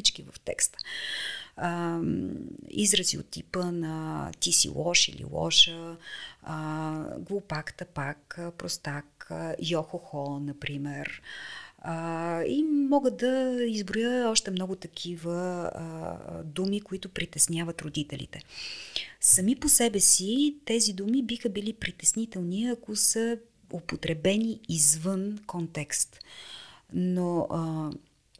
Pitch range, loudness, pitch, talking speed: 160-225 Hz, -27 LUFS, 180 Hz, 90 wpm